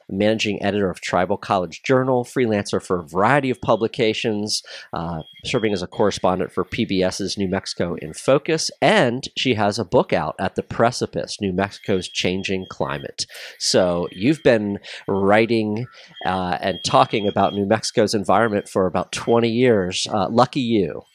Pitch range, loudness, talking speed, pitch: 95-115 Hz, -21 LUFS, 155 wpm, 105 Hz